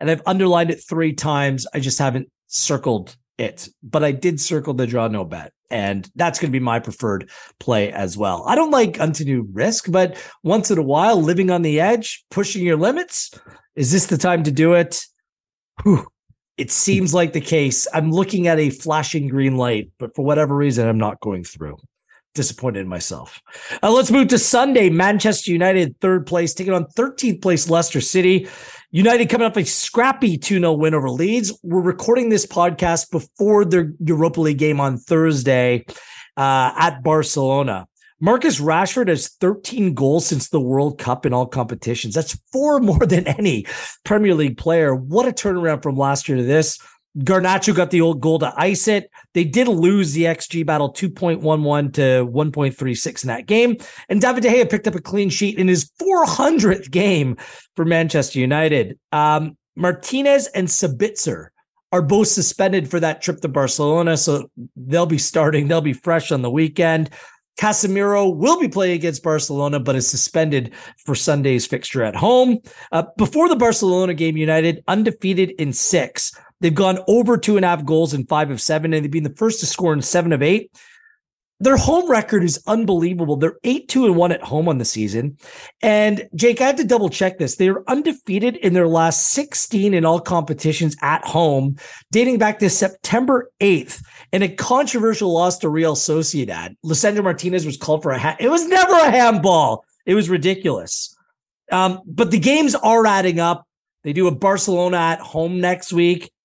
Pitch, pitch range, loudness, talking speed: 170 Hz, 150-200 Hz, -18 LUFS, 185 wpm